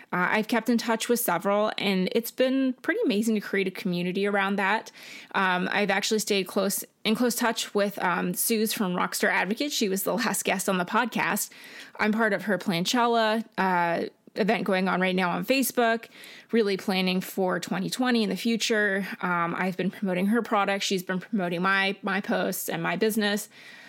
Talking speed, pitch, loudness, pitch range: 190 wpm, 205 Hz, -26 LUFS, 190-225 Hz